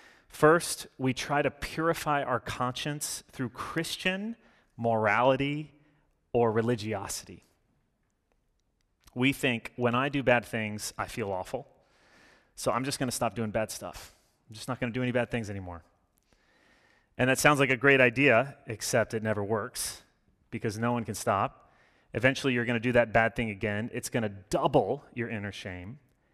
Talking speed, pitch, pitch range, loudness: 165 wpm, 120 Hz, 110-135 Hz, -29 LUFS